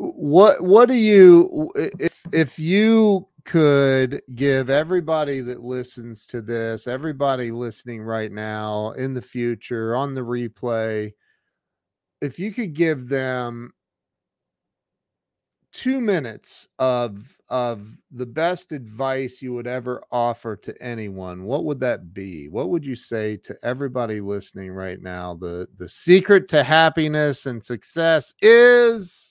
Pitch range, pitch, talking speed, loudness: 115-160 Hz, 125 Hz, 130 wpm, -19 LUFS